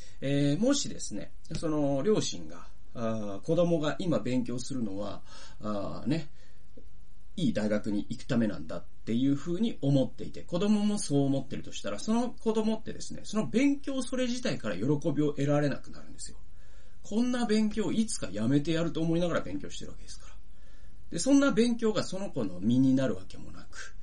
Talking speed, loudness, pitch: 365 characters per minute, -30 LUFS, 140 Hz